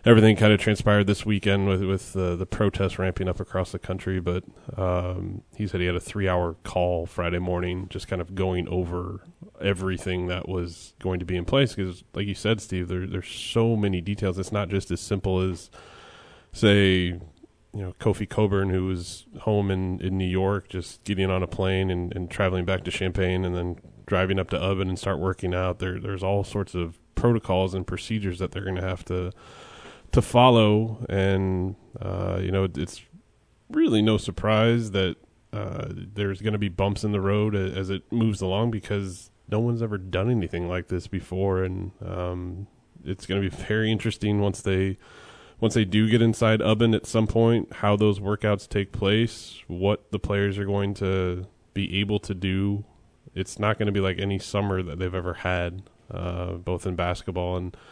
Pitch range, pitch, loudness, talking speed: 90-105 Hz, 95 Hz, -25 LUFS, 195 wpm